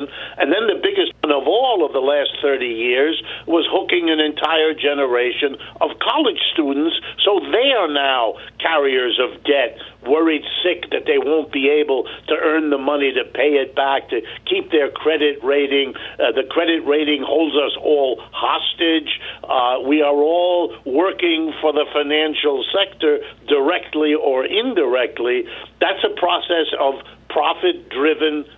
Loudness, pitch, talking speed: -18 LUFS, 160 Hz, 155 wpm